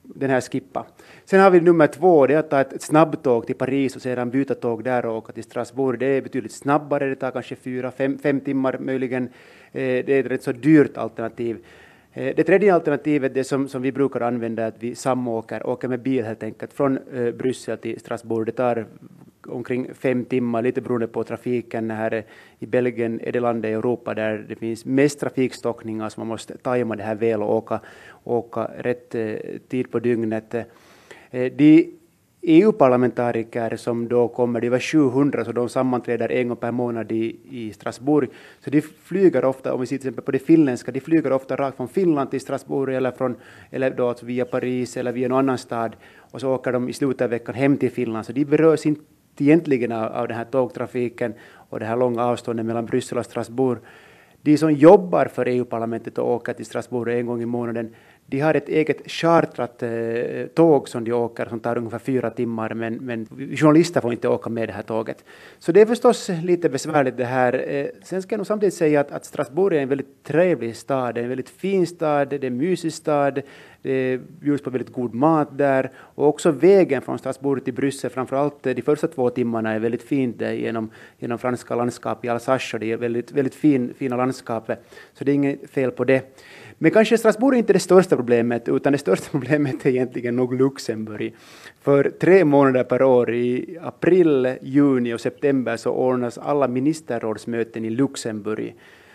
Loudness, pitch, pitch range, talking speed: -21 LUFS, 125 Hz, 120-140 Hz, 195 wpm